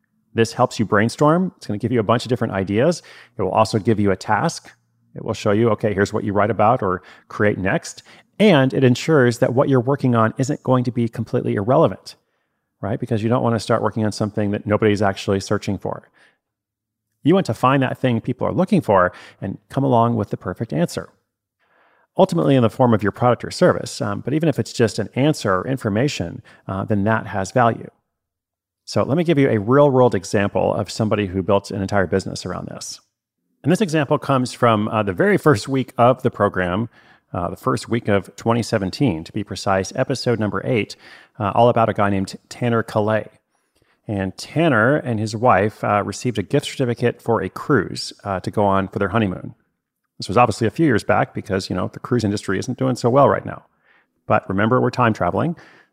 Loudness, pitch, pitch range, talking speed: -19 LUFS, 115 Hz, 100-125 Hz, 210 wpm